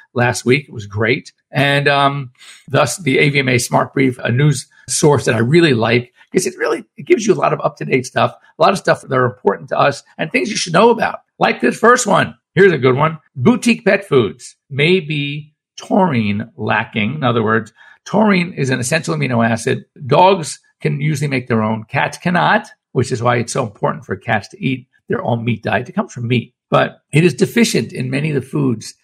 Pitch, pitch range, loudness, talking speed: 140 Hz, 120-180 Hz, -16 LUFS, 215 wpm